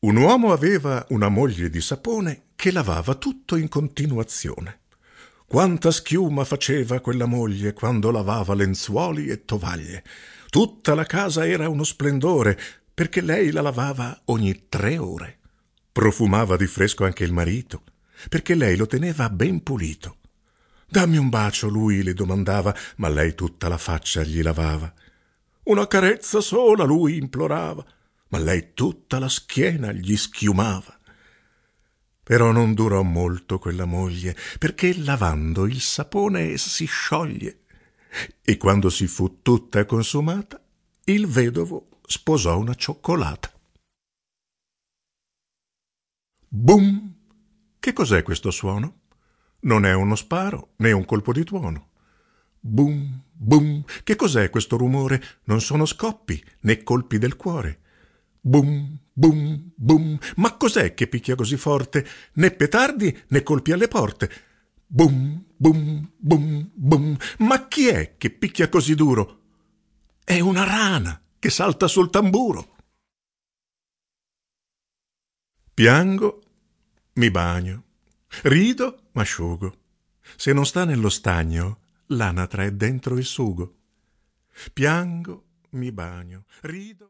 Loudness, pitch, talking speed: -21 LUFS, 125 Hz, 120 wpm